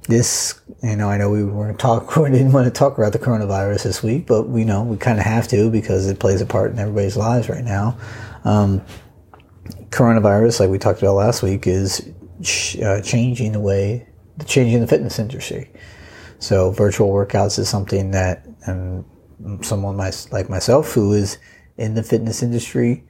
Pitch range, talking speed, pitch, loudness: 100-115 Hz, 185 wpm, 105 Hz, -18 LUFS